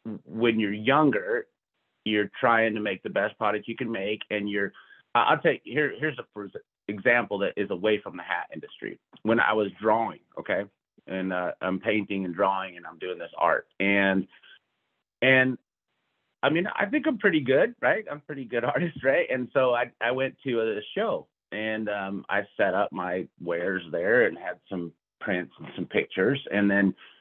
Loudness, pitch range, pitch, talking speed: -26 LUFS, 100-130 Hz, 110 Hz, 185 wpm